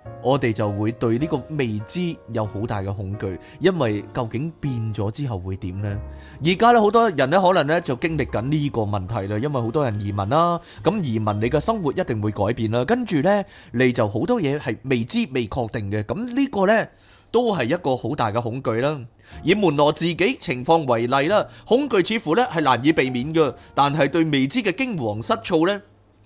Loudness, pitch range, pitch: -21 LUFS, 110-165 Hz, 130 Hz